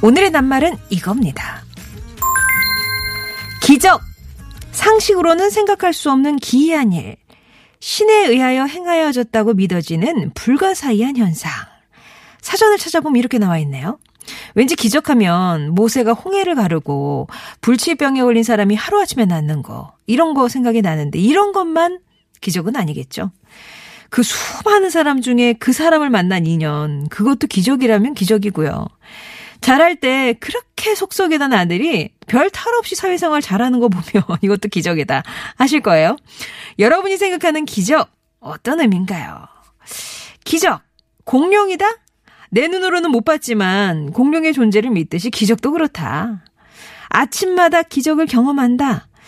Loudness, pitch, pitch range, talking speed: -15 LUFS, 245 Hz, 205-320 Hz, 295 characters per minute